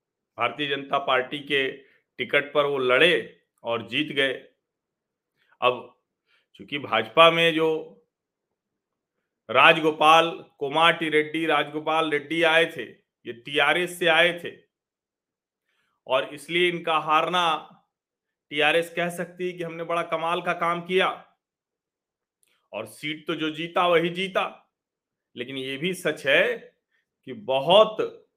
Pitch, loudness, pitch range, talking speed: 160 Hz, -23 LUFS, 145-170 Hz, 120 wpm